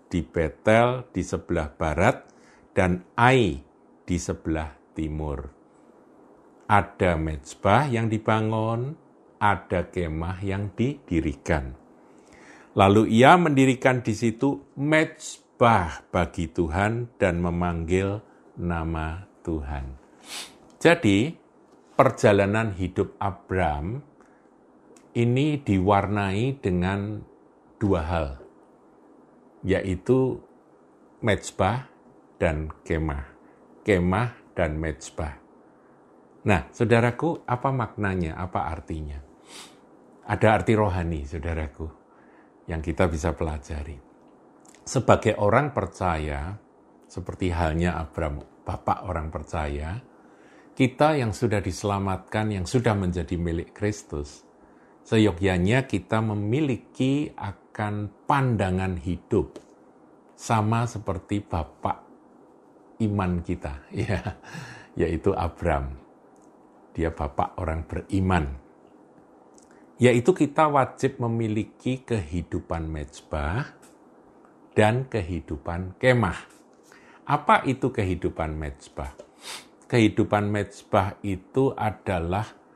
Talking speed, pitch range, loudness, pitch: 80 wpm, 85-110 Hz, -25 LUFS, 95 Hz